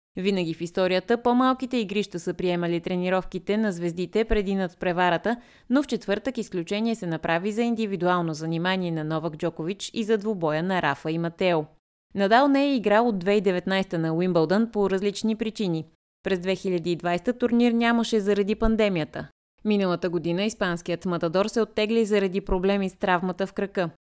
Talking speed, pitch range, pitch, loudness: 150 wpm, 175-220 Hz, 190 Hz, -25 LUFS